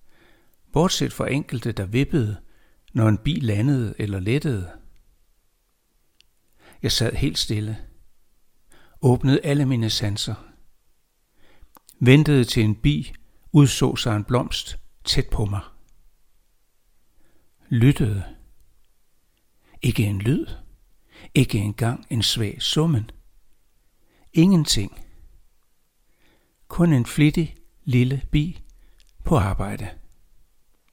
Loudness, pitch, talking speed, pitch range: -22 LUFS, 115 Hz, 90 wpm, 105-140 Hz